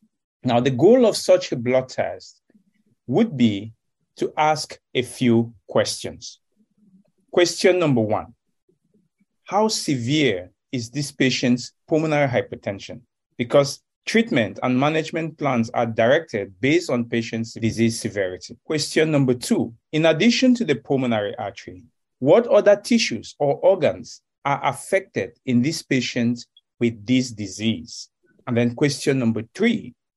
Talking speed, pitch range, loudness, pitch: 125 wpm, 120-180 Hz, -21 LUFS, 140 Hz